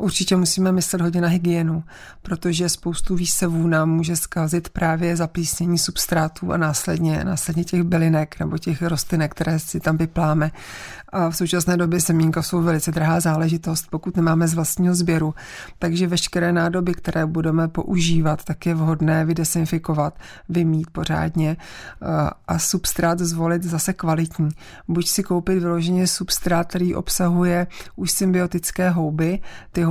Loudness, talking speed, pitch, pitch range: -21 LUFS, 140 wpm, 170 Hz, 160-175 Hz